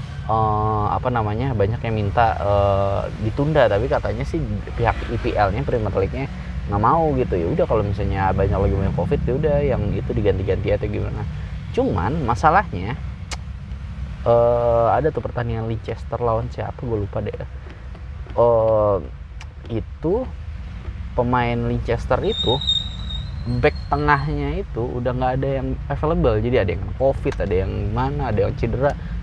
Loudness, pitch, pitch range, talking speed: -21 LUFS, 105 Hz, 95-120 Hz, 145 wpm